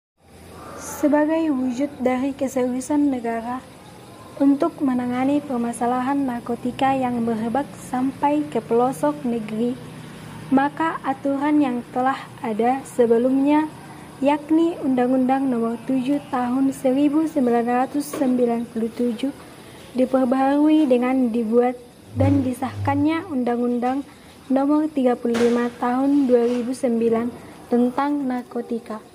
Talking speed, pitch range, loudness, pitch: 80 wpm, 245-280 Hz, -21 LUFS, 260 Hz